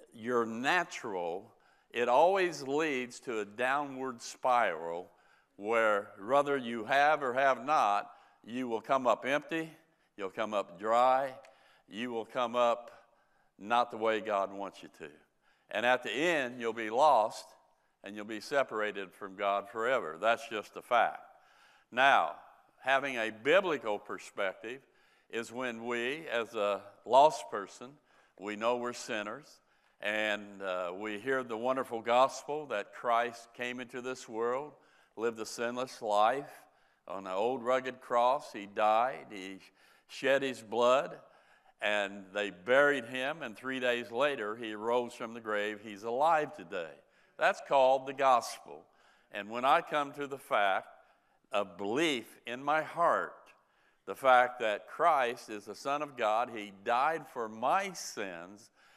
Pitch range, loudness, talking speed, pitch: 105-130 Hz, -32 LUFS, 145 wpm, 120 Hz